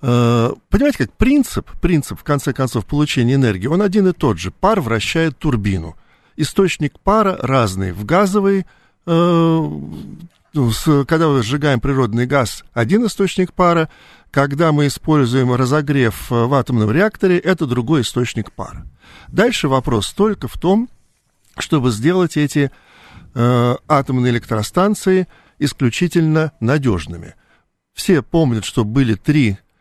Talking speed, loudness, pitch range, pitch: 120 wpm, -16 LUFS, 120-170 Hz, 145 Hz